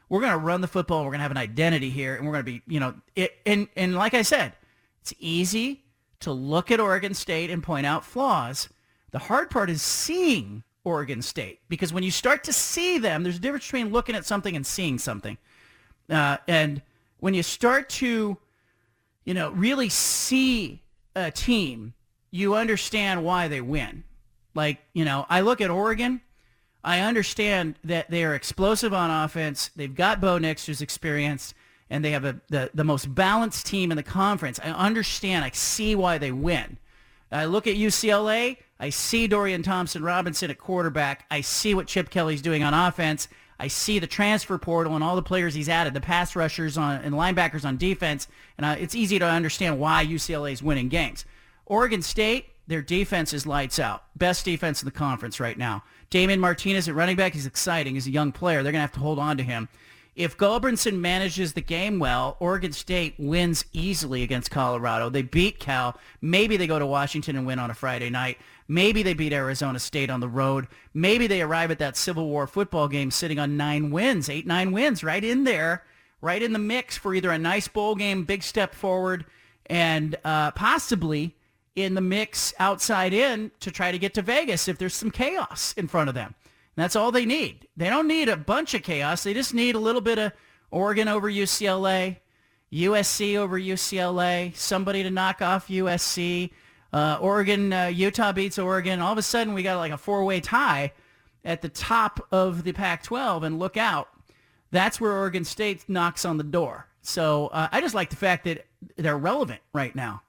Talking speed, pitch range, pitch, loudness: 200 wpm, 145-200 Hz, 175 Hz, -25 LUFS